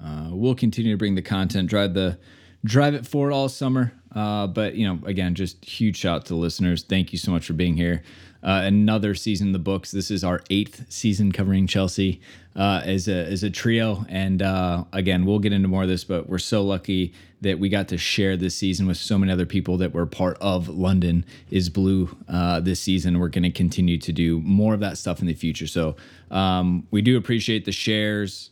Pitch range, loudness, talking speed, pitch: 90-100 Hz, -23 LUFS, 225 wpm, 95 Hz